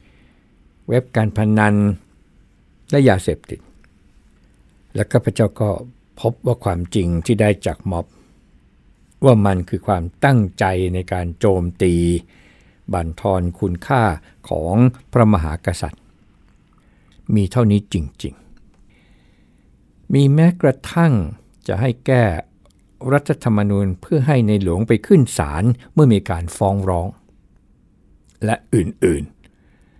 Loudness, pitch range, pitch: -18 LUFS, 90-120 Hz, 100 Hz